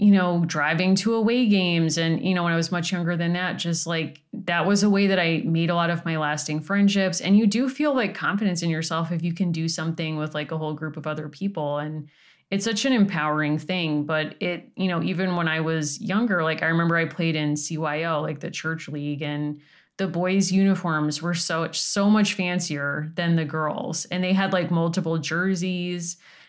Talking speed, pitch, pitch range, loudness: 220 wpm, 170 Hz, 155-190 Hz, -24 LUFS